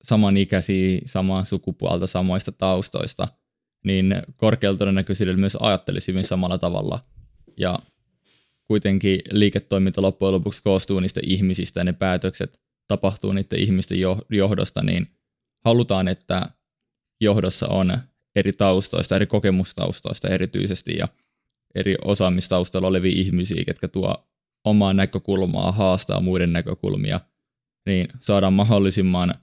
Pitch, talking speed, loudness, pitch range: 95 Hz, 110 wpm, -22 LUFS, 95-100 Hz